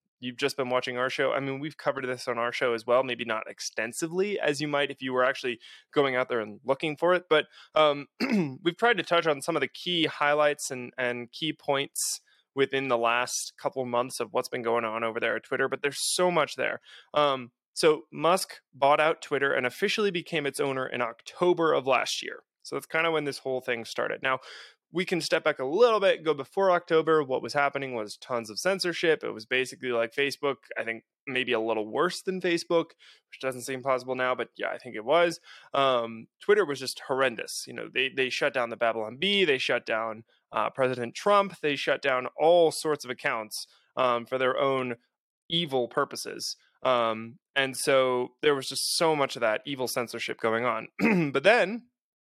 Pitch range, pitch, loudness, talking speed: 125-160 Hz, 135 Hz, -27 LUFS, 210 wpm